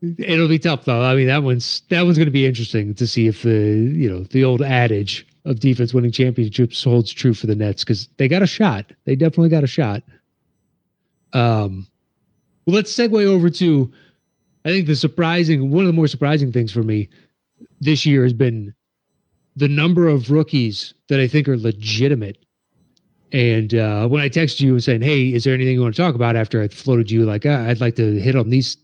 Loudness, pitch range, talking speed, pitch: -17 LUFS, 115-155 Hz, 210 wpm, 130 Hz